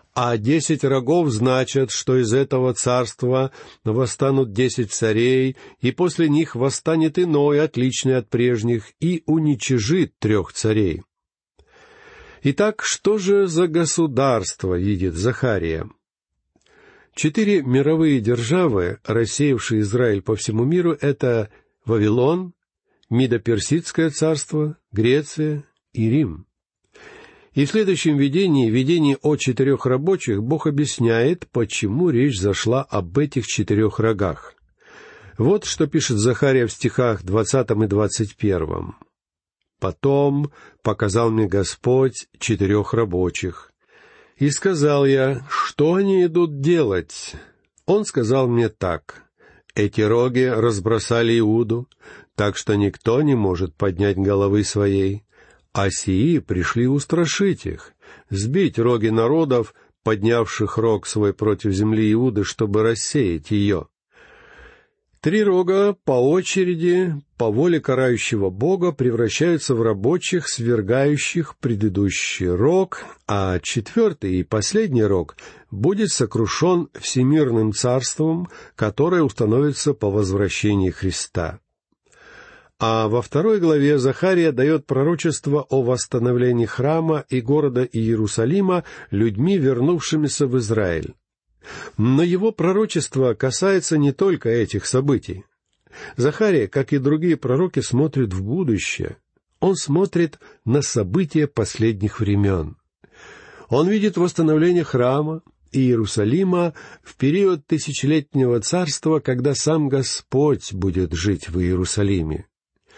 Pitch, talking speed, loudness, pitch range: 130 Hz, 105 wpm, -20 LUFS, 110-155 Hz